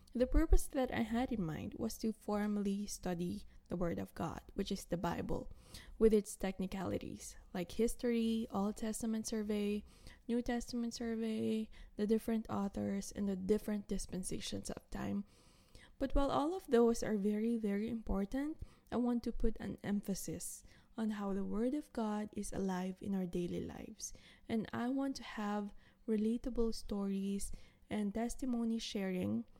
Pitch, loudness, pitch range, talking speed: 215 Hz, -39 LUFS, 200-235 Hz, 155 wpm